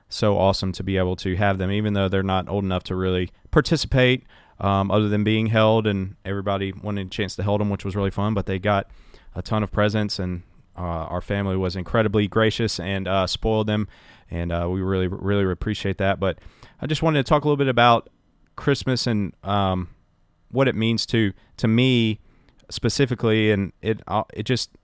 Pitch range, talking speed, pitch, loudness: 95-110 Hz, 200 wpm, 100 Hz, -22 LUFS